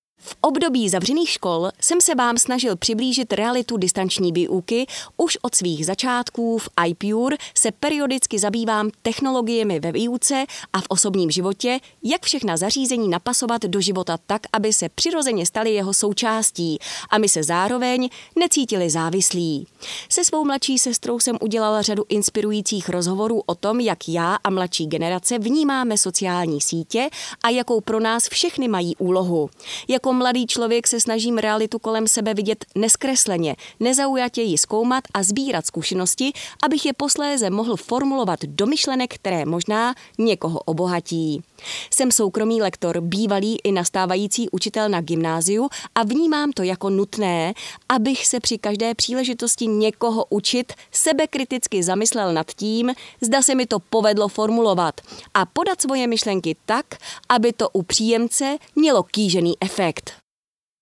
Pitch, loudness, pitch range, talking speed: 220 Hz, -20 LUFS, 190-250 Hz, 140 wpm